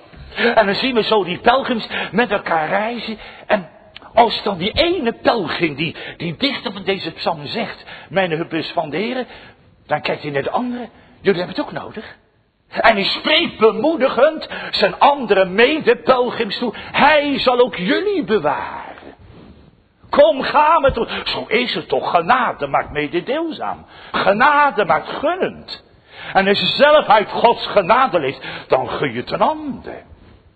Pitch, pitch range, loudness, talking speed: 225 Hz, 175-270 Hz, -17 LUFS, 155 wpm